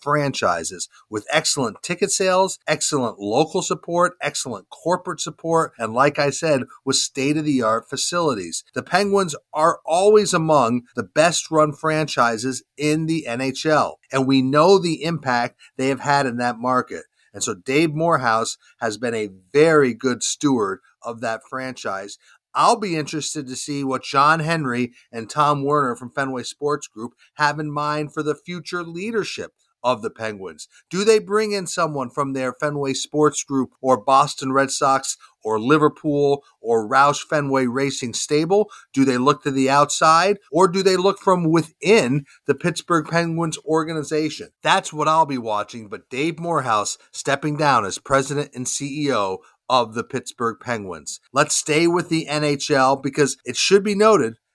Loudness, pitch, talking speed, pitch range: -20 LUFS, 150 Hz, 160 wpm, 135-165 Hz